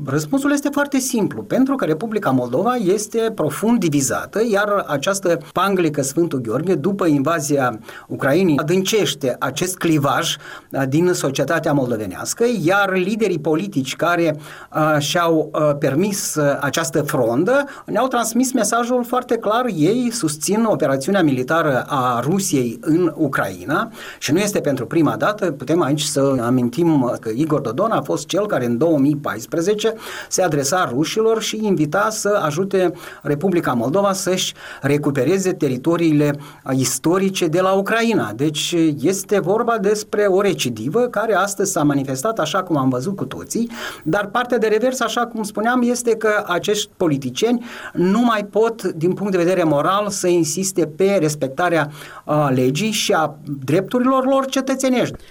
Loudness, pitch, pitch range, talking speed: -18 LUFS, 175 Hz, 150-210 Hz, 140 wpm